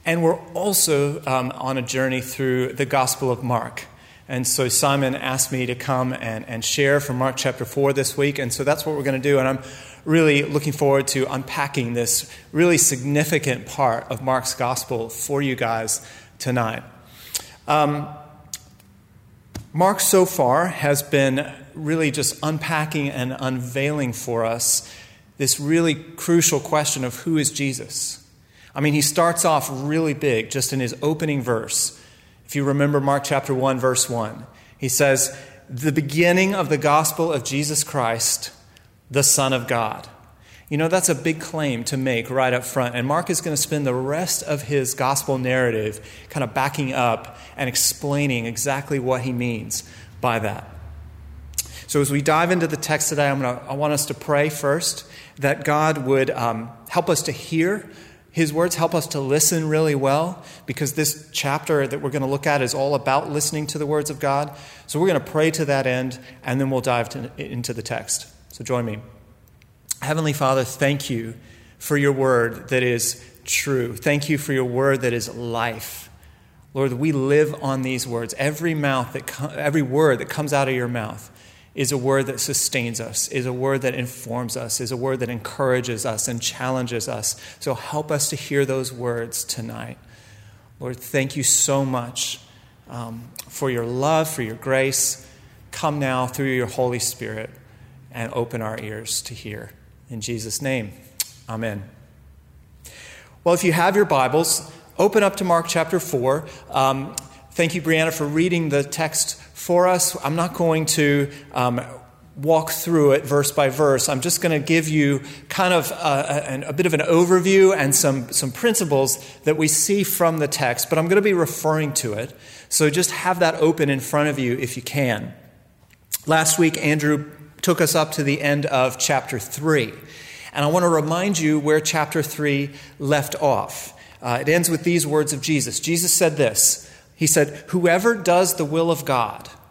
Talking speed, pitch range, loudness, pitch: 185 wpm, 125-155 Hz, -21 LUFS, 140 Hz